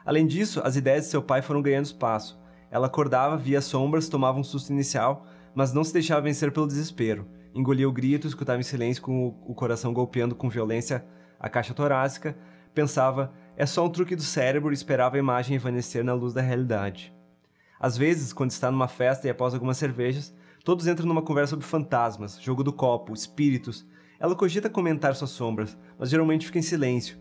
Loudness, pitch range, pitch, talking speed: -26 LUFS, 120-150 Hz, 130 Hz, 190 wpm